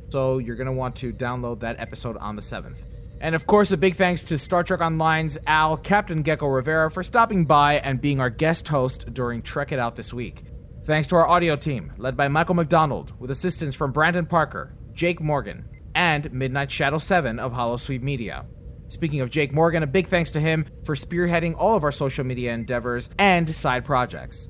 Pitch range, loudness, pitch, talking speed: 125-165 Hz, -23 LUFS, 145 Hz, 205 wpm